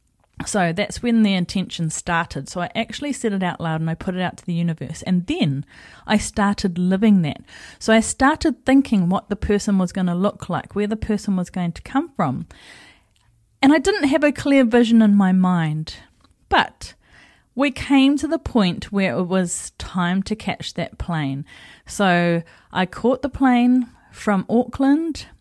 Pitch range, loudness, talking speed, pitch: 175-240 Hz, -20 LUFS, 185 wpm, 195 Hz